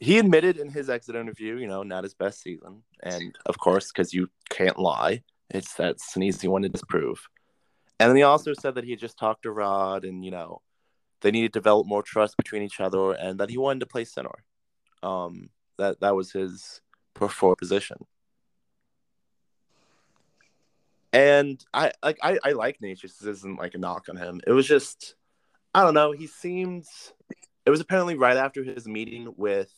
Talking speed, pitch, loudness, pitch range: 185 wpm, 105 Hz, -25 LUFS, 95-135 Hz